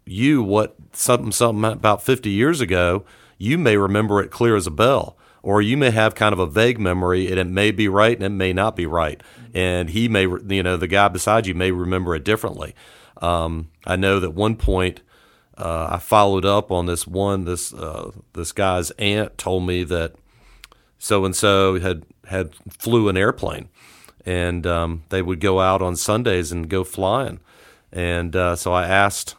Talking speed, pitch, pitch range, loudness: 190 wpm, 95 Hz, 90-105 Hz, -20 LUFS